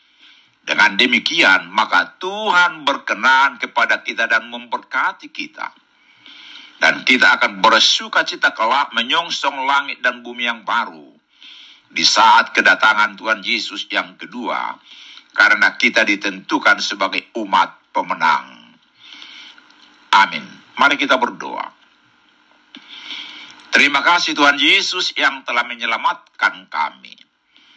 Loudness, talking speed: -15 LUFS, 100 wpm